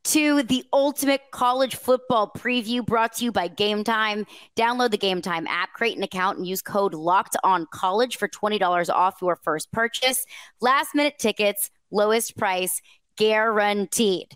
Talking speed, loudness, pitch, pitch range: 155 wpm, -23 LUFS, 215 Hz, 190-245 Hz